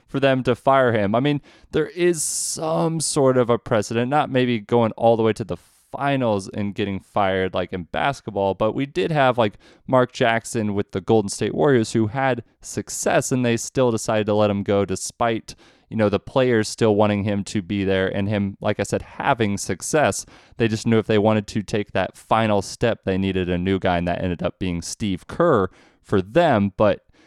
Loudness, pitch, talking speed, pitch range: -21 LUFS, 110 Hz, 210 wpm, 100-125 Hz